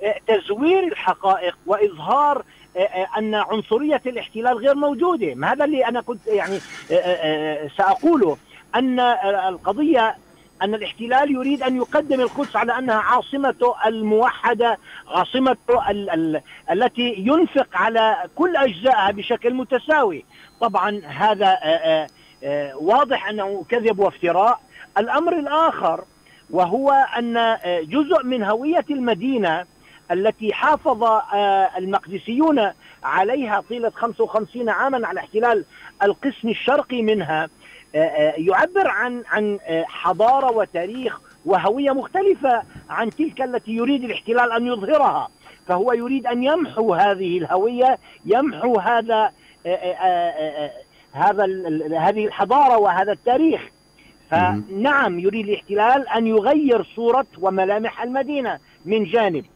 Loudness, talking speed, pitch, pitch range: -20 LUFS, 100 wpm, 225 Hz, 195-265 Hz